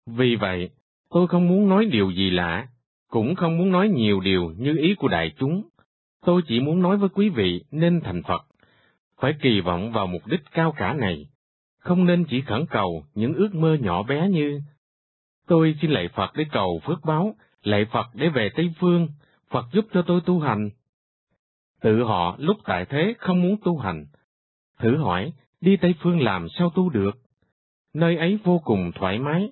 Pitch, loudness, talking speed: 145 Hz, -22 LUFS, 190 wpm